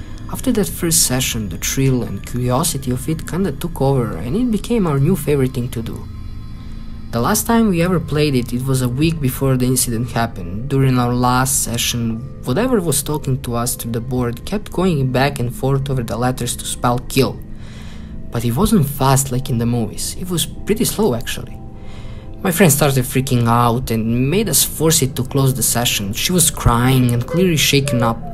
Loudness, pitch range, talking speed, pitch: -17 LUFS, 115-145 Hz, 200 wpm, 125 Hz